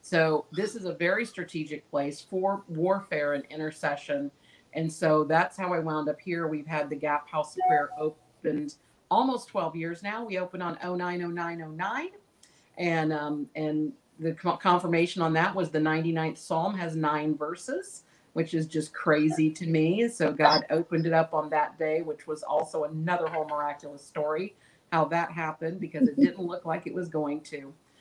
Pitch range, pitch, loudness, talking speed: 150-175 Hz, 160 Hz, -29 LUFS, 175 wpm